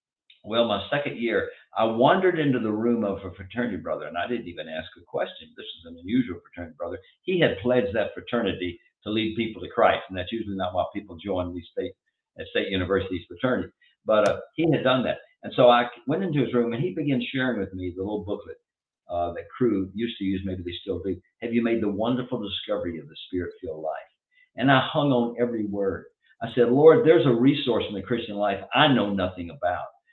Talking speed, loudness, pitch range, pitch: 220 wpm, -25 LUFS, 95-130 Hz, 115 Hz